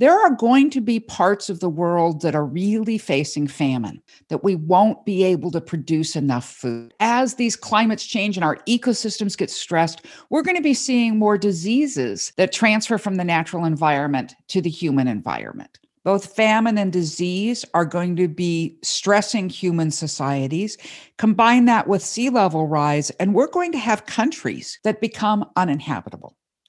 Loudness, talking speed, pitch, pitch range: -20 LUFS, 170 wpm, 190 Hz, 160-220 Hz